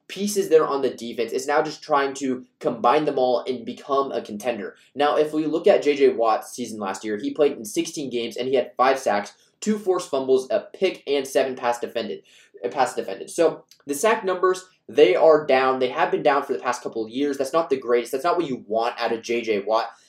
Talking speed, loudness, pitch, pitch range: 235 wpm, -23 LUFS, 140 Hz, 125-170 Hz